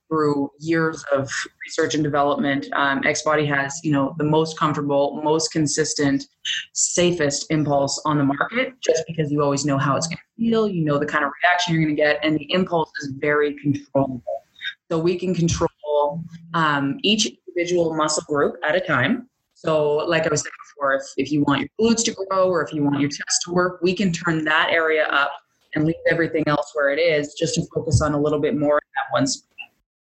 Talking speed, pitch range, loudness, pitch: 210 wpm, 145-165 Hz, -21 LUFS, 155 Hz